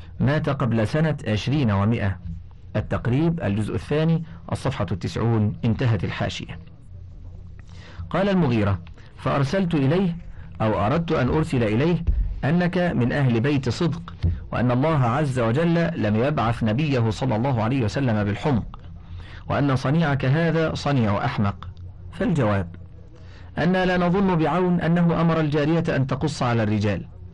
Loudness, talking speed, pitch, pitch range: -22 LUFS, 120 wpm, 120 Hz, 100-155 Hz